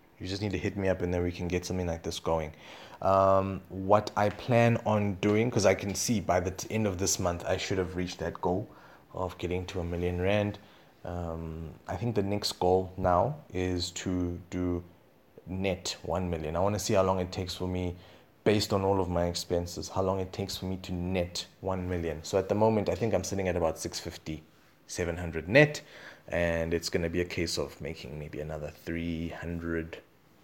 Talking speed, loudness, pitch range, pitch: 215 wpm, -30 LUFS, 85-100 Hz, 90 Hz